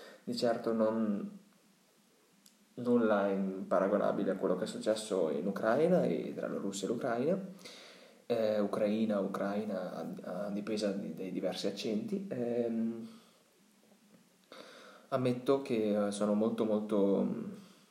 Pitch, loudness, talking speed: 115 Hz, -34 LUFS, 115 wpm